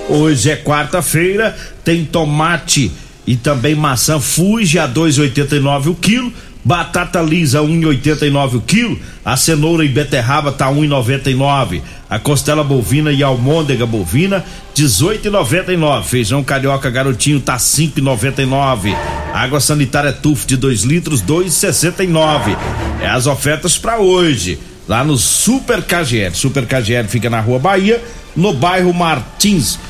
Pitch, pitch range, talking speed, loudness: 150 Hz, 135-165 Hz, 145 wpm, -13 LUFS